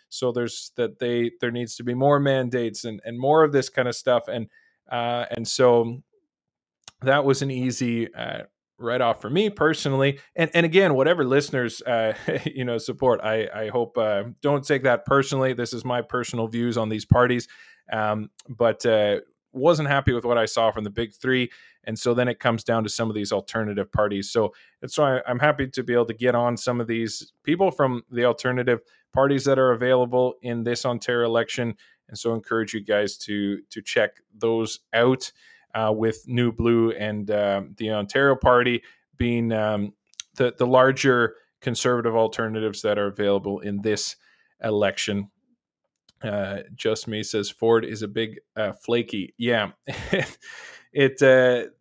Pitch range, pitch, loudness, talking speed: 110-130 Hz, 120 Hz, -23 LUFS, 180 wpm